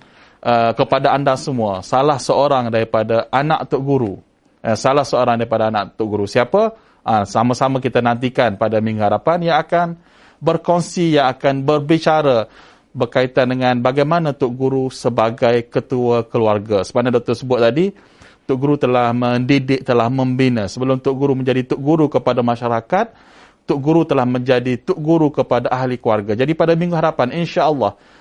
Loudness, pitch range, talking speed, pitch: -17 LUFS, 120-145 Hz, 150 wpm, 130 Hz